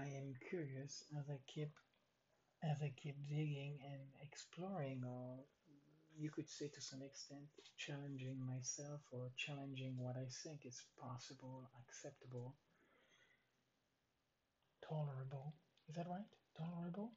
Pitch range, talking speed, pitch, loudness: 130-150 Hz, 120 wpm, 140 Hz, -51 LUFS